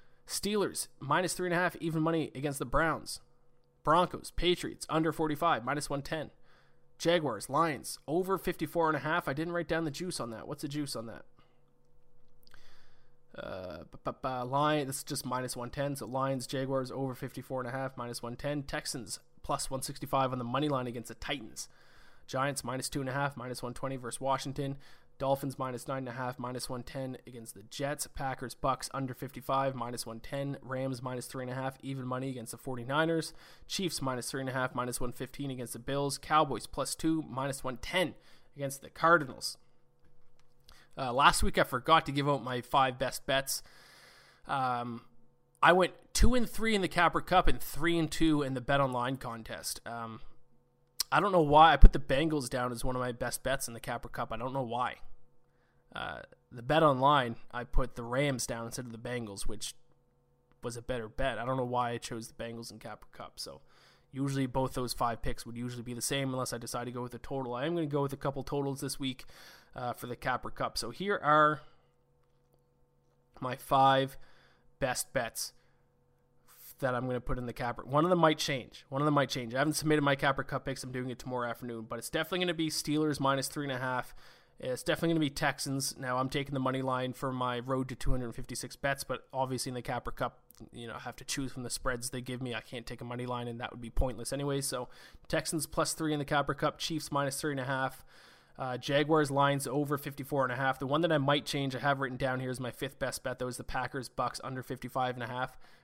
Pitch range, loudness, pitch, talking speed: 125-145 Hz, -33 LUFS, 130 Hz, 215 wpm